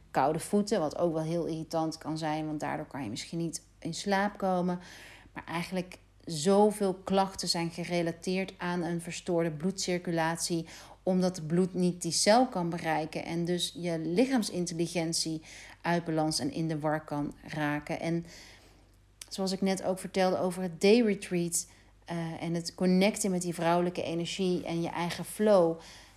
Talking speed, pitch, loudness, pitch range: 160 wpm, 170 Hz, -31 LUFS, 160-185 Hz